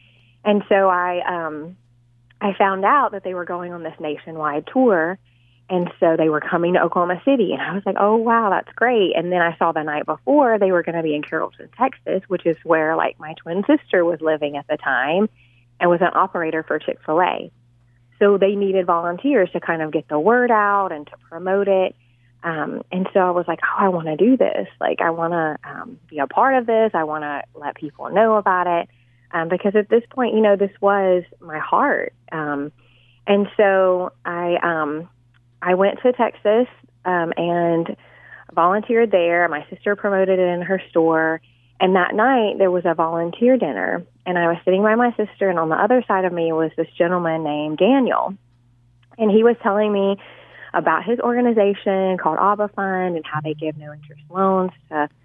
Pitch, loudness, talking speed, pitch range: 175 Hz, -19 LUFS, 205 wpm, 155-200 Hz